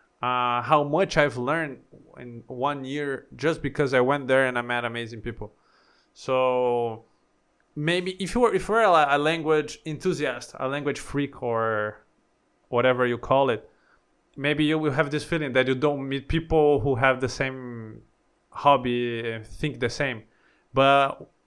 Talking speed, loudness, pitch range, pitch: 155 wpm, -24 LUFS, 120-150 Hz, 135 Hz